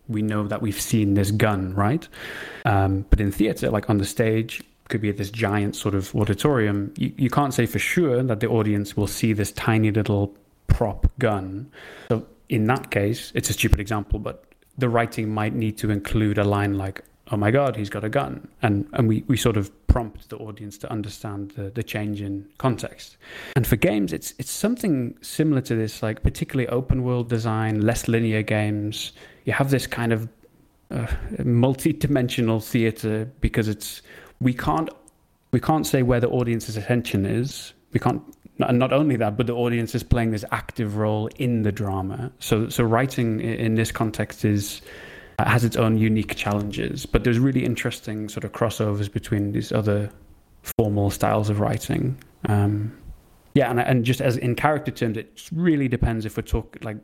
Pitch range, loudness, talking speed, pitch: 105-125 Hz, -23 LUFS, 190 wpm, 110 Hz